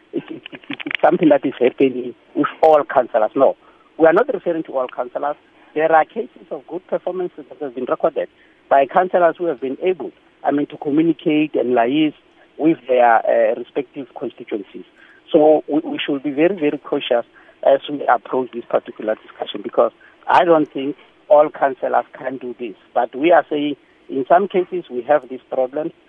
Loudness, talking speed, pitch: -18 LUFS, 185 wpm, 155 Hz